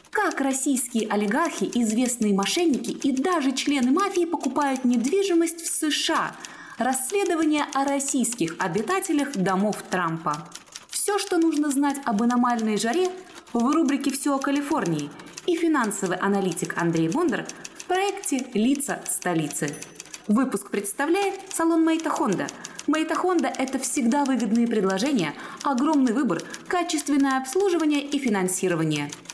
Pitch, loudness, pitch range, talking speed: 275 Hz, -24 LUFS, 220-320 Hz, 110 wpm